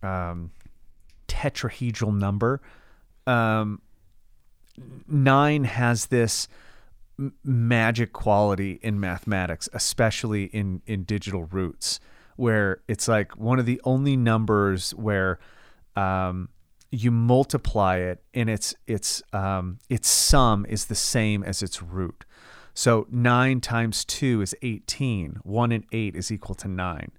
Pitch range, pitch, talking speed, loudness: 95-120 Hz, 105 Hz, 120 wpm, -24 LUFS